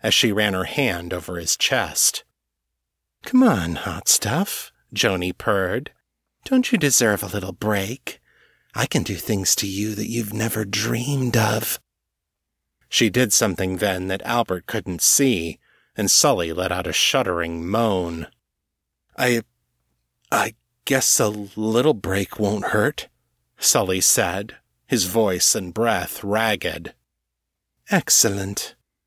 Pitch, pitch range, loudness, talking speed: 100 Hz, 85-115 Hz, -20 LUFS, 130 wpm